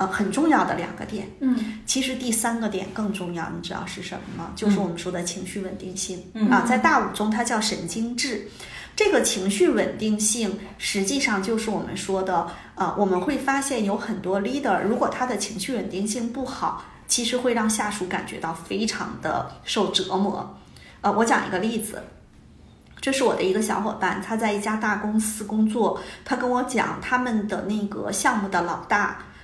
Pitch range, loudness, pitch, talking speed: 190-235 Hz, -24 LUFS, 210 Hz, 290 characters per minute